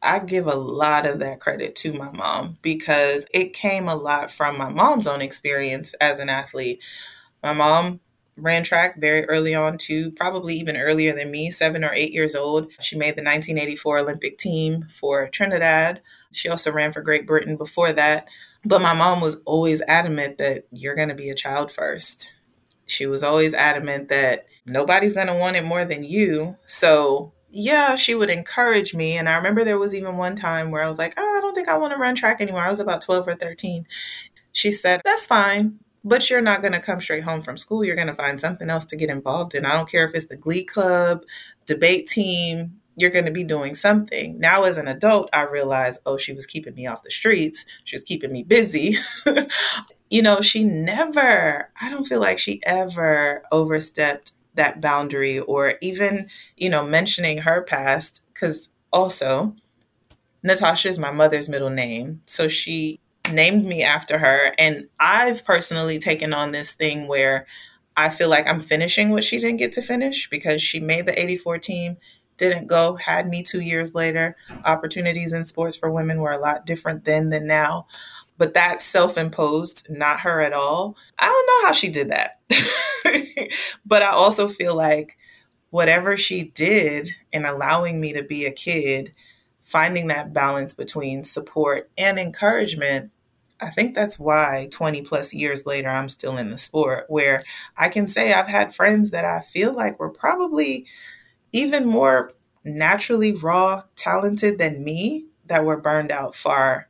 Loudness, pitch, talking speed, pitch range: -20 LUFS, 160 Hz, 185 wpm, 150-190 Hz